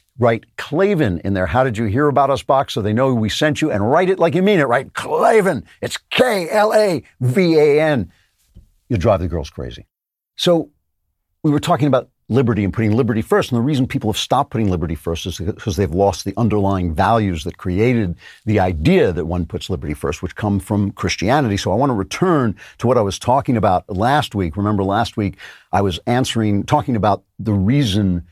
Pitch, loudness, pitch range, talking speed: 105 Hz, -17 LUFS, 95-135 Hz, 210 wpm